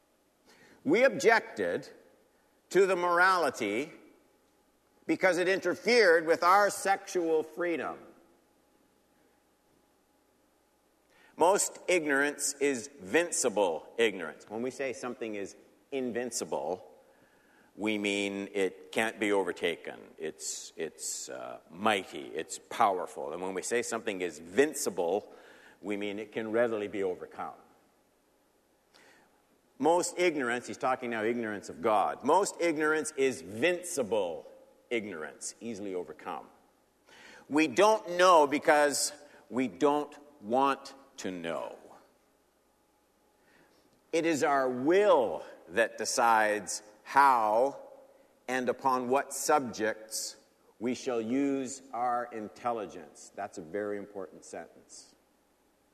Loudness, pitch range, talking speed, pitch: -30 LUFS, 115-195 Hz, 100 wpm, 140 Hz